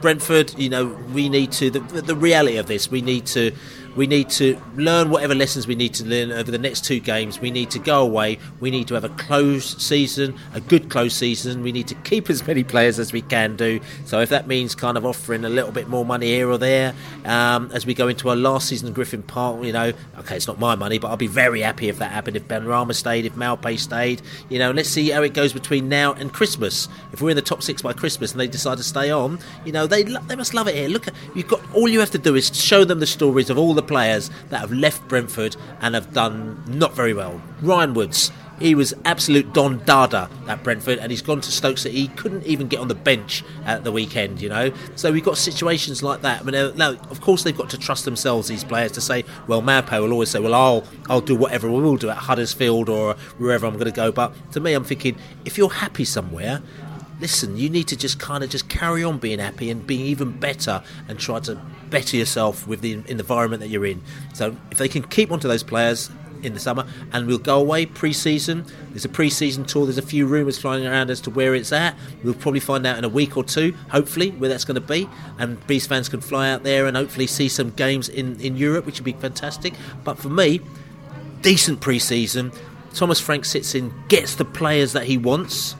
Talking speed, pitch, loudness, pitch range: 245 wpm, 135 Hz, -20 LUFS, 120-150 Hz